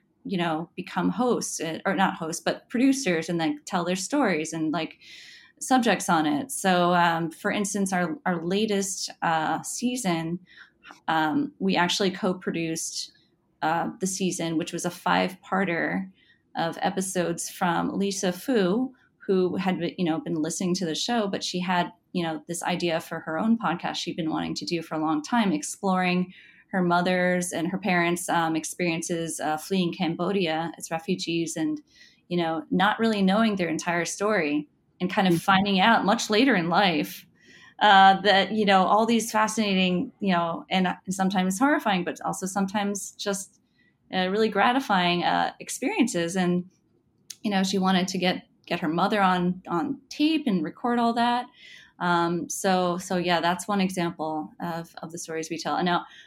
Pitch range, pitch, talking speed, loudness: 170-205 Hz, 185 Hz, 170 wpm, -25 LUFS